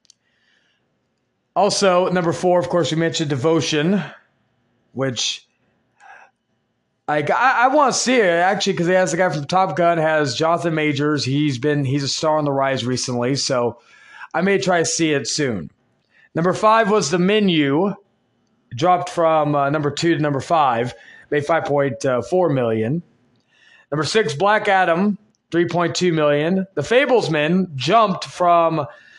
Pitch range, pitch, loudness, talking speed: 145-185 Hz, 165 Hz, -18 LUFS, 155 wpm